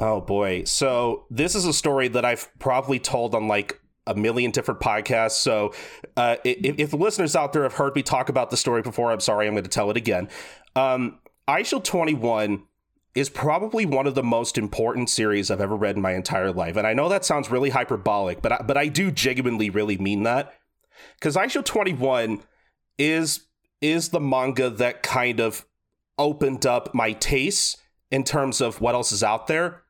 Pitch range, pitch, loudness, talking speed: 110-140 Hz, 125 Hz, -23 LUFS, 195 wpm